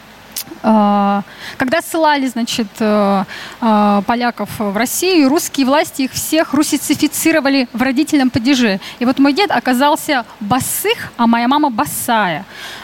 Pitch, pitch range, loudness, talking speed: 265 Hz, 230-300 Hz, -14 LUFS, 110 wpm